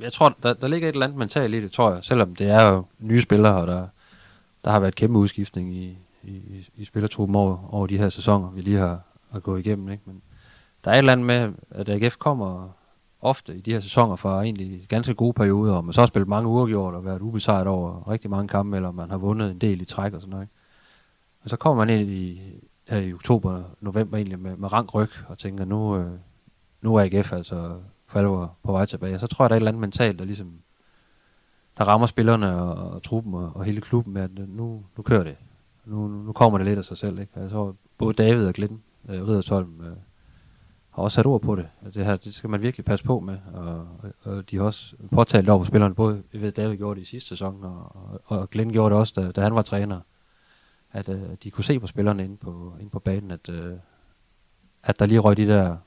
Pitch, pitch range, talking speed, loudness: 100 Hz, 95-110 Hz, 245 wpm, -23 LUFS